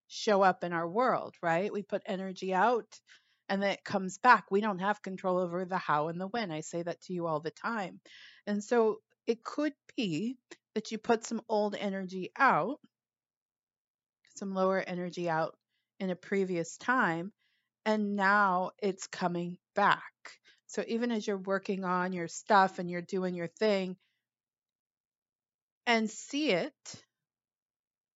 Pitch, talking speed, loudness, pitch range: 190 Hz, 160 wpm, -32 LUFS, 175-215 Hz